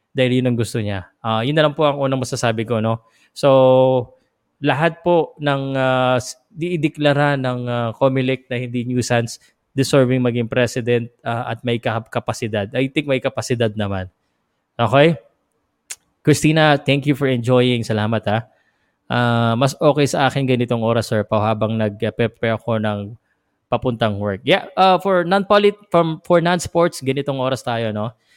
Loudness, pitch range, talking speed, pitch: -18 LUFS, 115-145 Hz, 155 wpm, 125 Hz